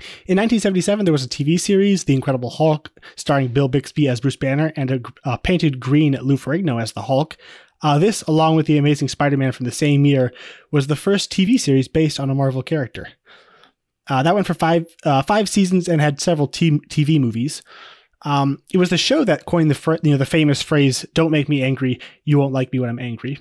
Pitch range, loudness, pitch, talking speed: 135-165 Hz, -18 LUFS, 150 Hz, 220 wpm